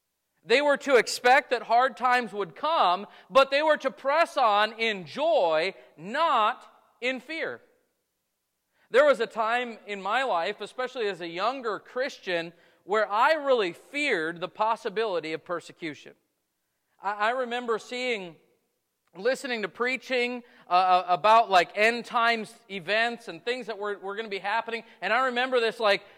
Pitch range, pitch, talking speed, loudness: 195-255 Hz, 230 Hz, 155 wpm, -26 LUFS